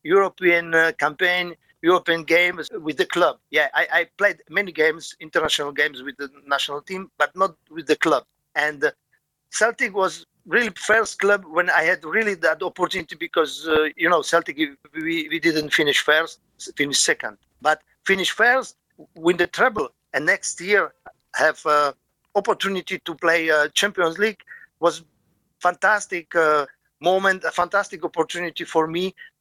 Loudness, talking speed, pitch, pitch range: -21 LUFS, 155 wpm, 175 Hz, 160-200 Hz